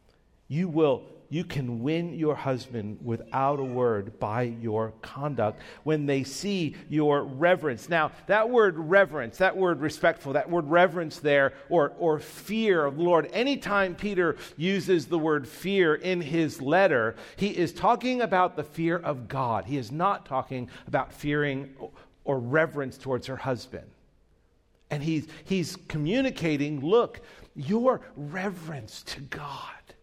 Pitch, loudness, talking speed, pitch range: 155 Hz, -27 LUFS, 145 wpm, 135-180 Hz